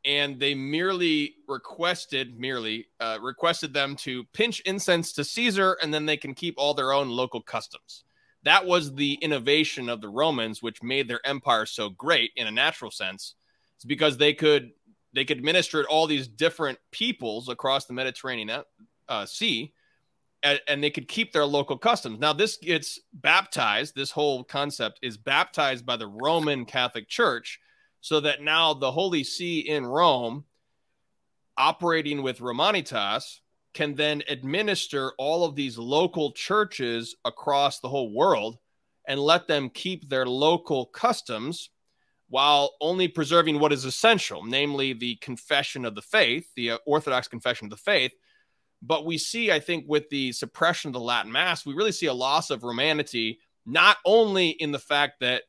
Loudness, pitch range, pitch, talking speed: -25 LUFS, 130-165 Hz, 145 Hz, 165 wpm